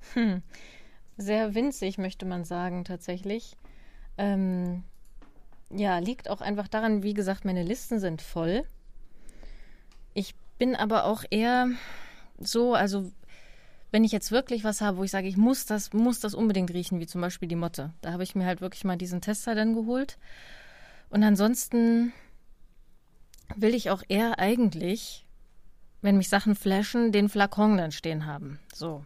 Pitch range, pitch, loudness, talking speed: 180-225 Hz, 205 Hz, -28 LUFS, 155 wpm